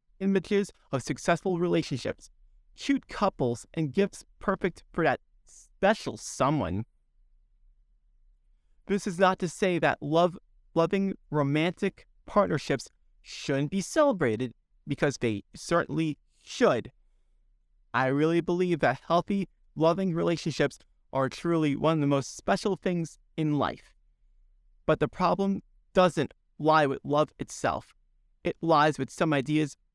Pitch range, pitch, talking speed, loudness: 140-185 Hz, 165 Hz, 120 wpm, -28 LUFS